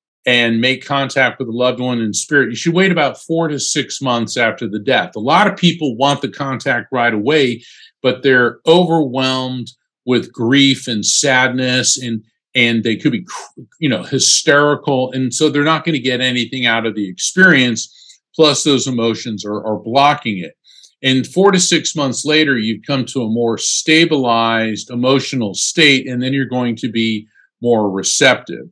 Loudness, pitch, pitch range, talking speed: -14 LUFS, 130 Hz, 115-145 Hz, 180 wpm